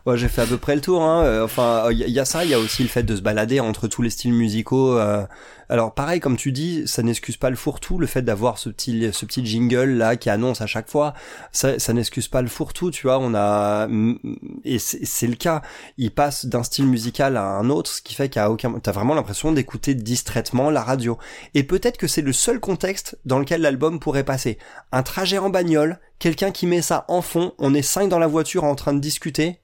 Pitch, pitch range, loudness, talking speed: 130 Hz, 115-155 Hz, -21 LUFS, 245 wpm